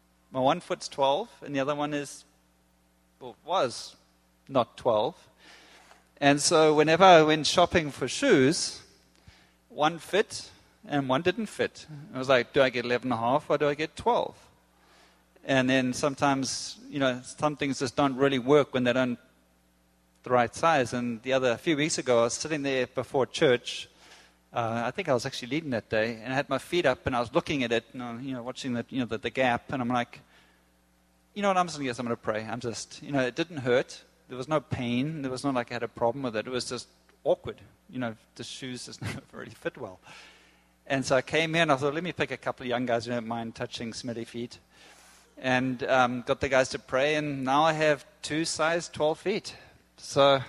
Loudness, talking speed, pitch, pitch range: -27 LUFS, 220 wpm, 130 Hz, 120-145 Hz